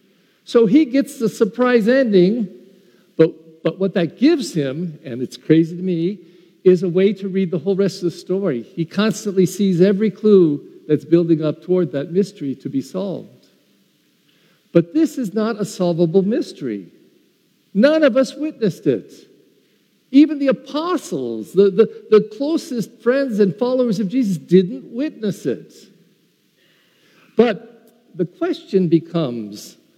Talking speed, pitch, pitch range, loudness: 145 wpm, 195 Hz, 175-240 Hz, -18 LUFS